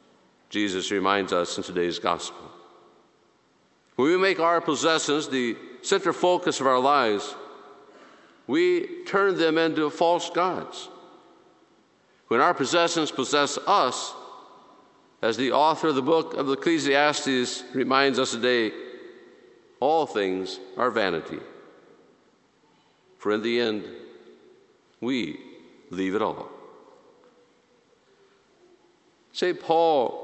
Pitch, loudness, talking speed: 160 Hz, -24 LUFS, 105 wpm